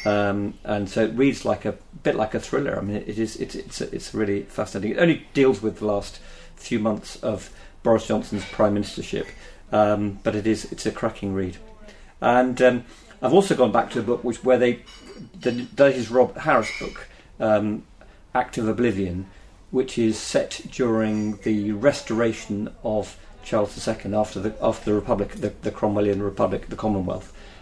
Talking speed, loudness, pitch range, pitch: 185 wpm, -24 LUFS, 100-120 Hz, 105 Hz